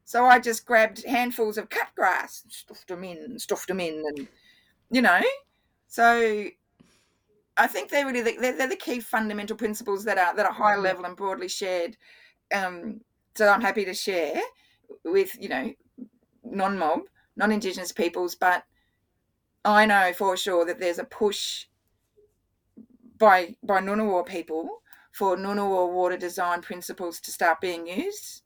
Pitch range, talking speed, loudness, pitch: 180-240 Hz, 155 wpm, -25 LUFS, 205 Hz